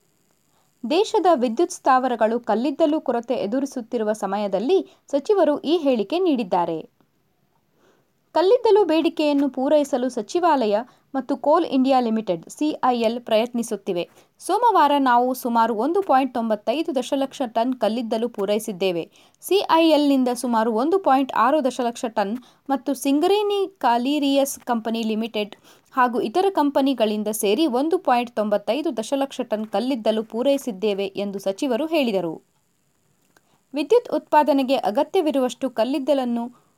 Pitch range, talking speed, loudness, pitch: 225-300 Hz, 100 wpm, -21 LUFS, 260 Hz